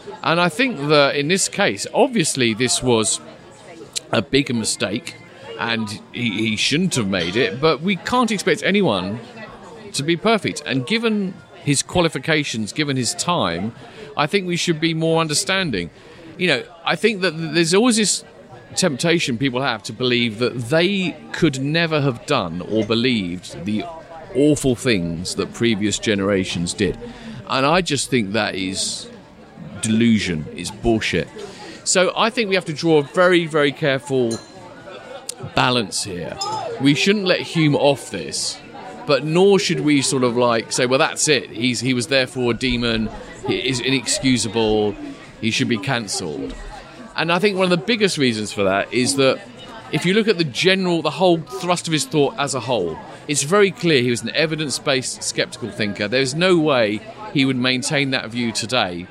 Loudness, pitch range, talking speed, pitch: -19 LUFS, 120-170 Hz, 170 wpm, 140 Hz